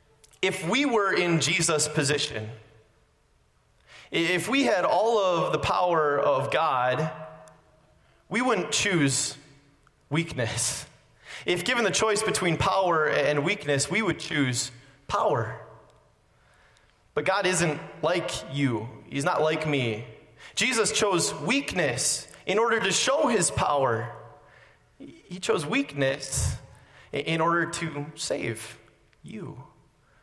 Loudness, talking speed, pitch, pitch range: -25 LUFS, 115 wpm, 150 Hz, 135-170 Hz